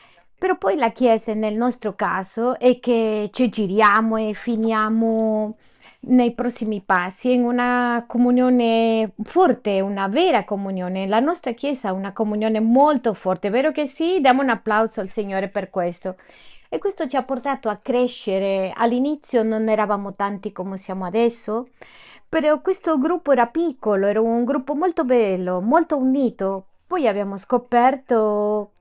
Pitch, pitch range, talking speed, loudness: 225 Hz, 205-255 Hz, 150 wpm, -20 LUFS